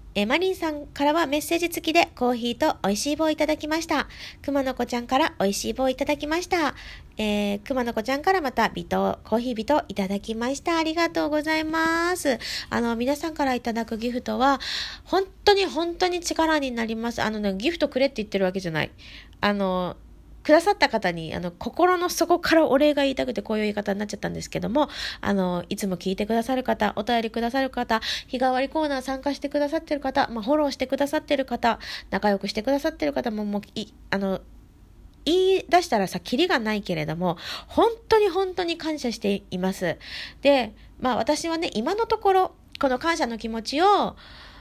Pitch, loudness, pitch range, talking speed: 265 Hz, -24 LUFS, 215-315 Hz, 410 characters per minute